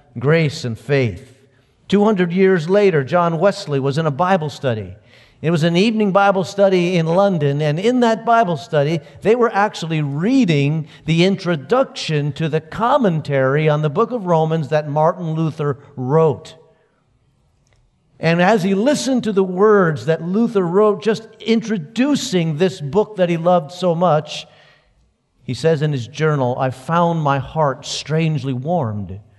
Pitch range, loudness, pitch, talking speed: 145-195 Hz, -17 LUFS, 160 Hz, 150 wpm